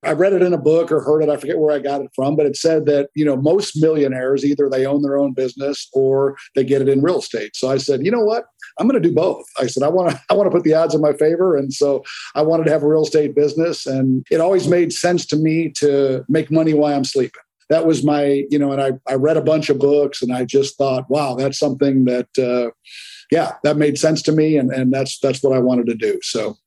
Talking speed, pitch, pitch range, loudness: 275 wpm, 145 Hz, 135-155 Hz, -17 LUFS